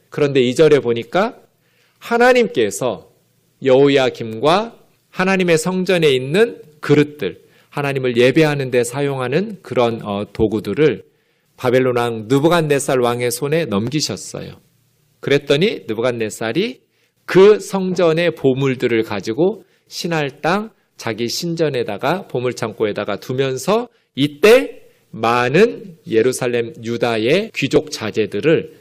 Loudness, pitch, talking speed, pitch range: -17 LUFS, 140 Hz, 260 characters per minute, 120-170 Hz